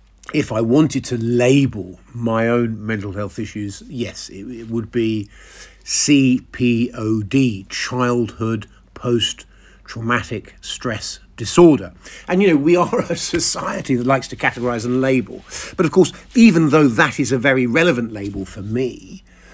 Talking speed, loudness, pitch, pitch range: 155 wpm, -18 LUFS, 120 Hz, 110-135 Hz